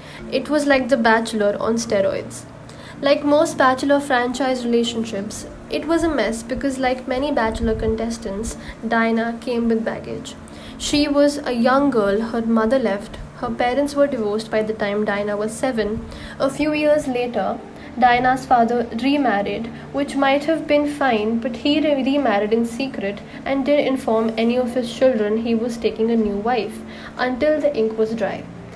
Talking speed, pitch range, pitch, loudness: 165 wpm, 225-275 Hz, 245 Hz, -20 LUFS